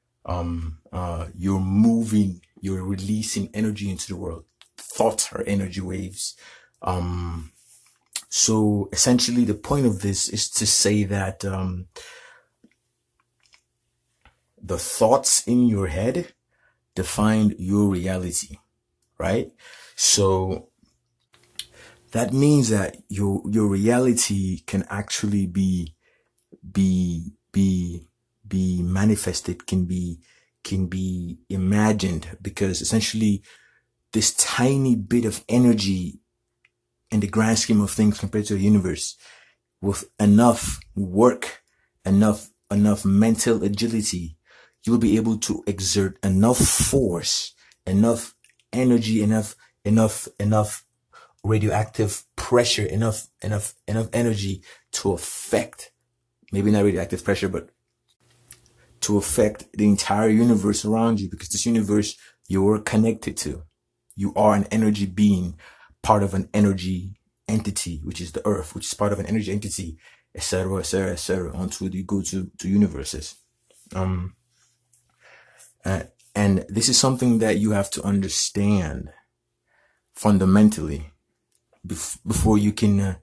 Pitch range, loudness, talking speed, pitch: 95-110 Hz, -22 LUFS, 120 wpm, 100 Hz